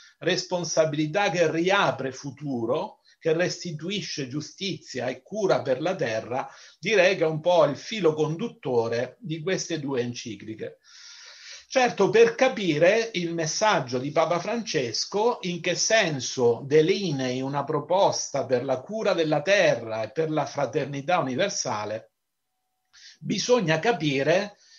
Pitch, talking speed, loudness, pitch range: 165 Hz, 120 wpm, -25 LUFS, 140-200 Hz